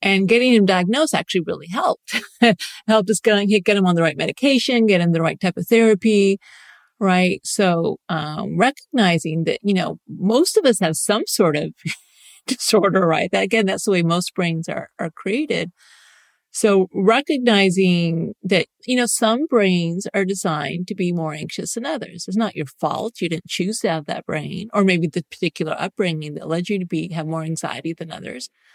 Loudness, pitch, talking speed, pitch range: -19 LUFS, 195 Hz, 190 wpm, 170-220 Hz